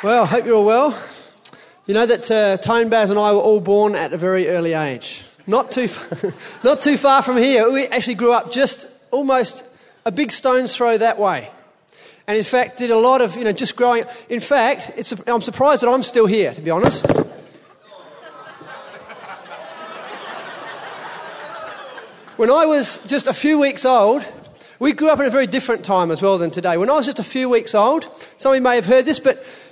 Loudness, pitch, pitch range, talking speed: -17 LUFS, 240 Hz, 215-265 Hz, 205 wpm